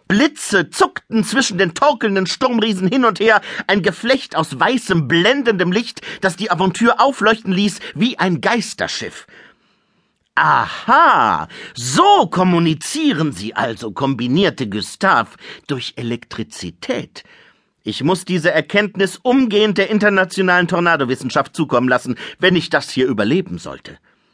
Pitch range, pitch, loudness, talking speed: 160-230 Hz, 190 Hz, -16 LUFS, 120 wpm